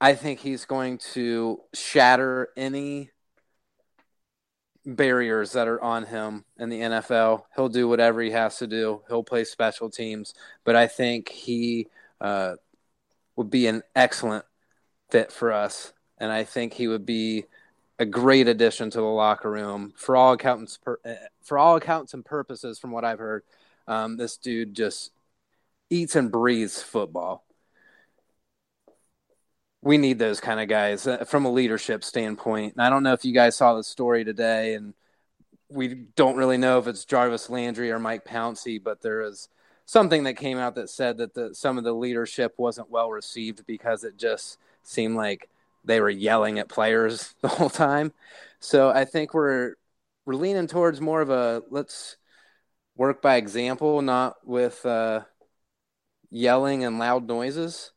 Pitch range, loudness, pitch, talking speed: 110-130 Hz, -24 LUFS, 120 Hz, 160 wpm